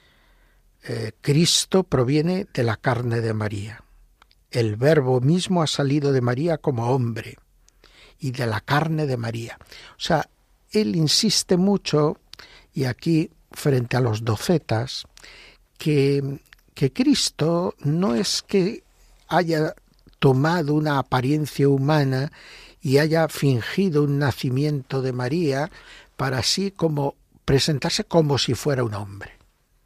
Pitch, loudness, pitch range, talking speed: 140 Hz, -22 LUFS, 125-160 Hz, 125 wpm